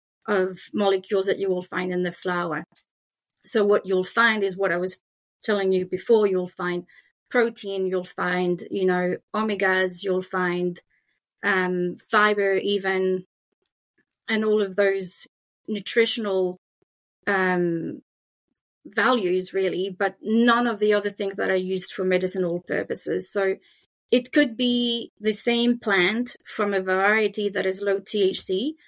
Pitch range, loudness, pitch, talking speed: 185-215 Hz, -24 LUFS, 195 Hz, 140 wpm